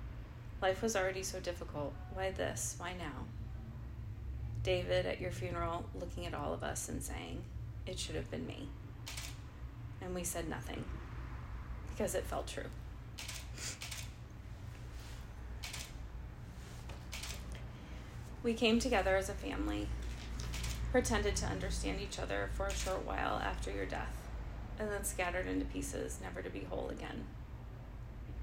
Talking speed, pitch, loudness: 130 wpm, 95 Hz, -40 LUFS